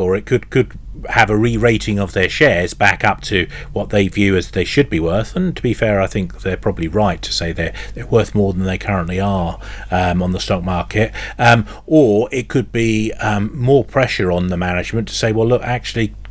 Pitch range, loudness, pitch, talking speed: 95-120 Hz, -16 LUFS, 105 Hz, 230 wpm